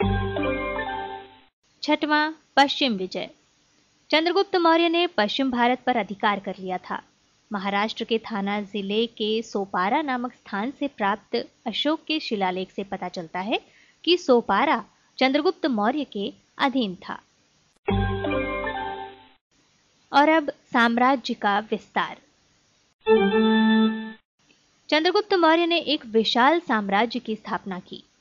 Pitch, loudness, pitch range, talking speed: 225 Hz, -23 LUFS, 200-285 Hz, 110 wpm